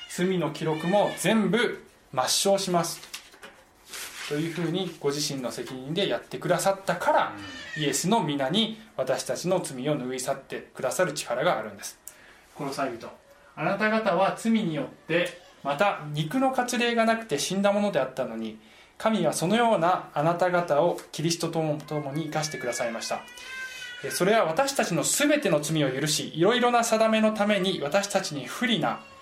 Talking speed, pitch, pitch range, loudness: 330 characters per minute, 180 Hz, 150-215 Hz, -26 LUFS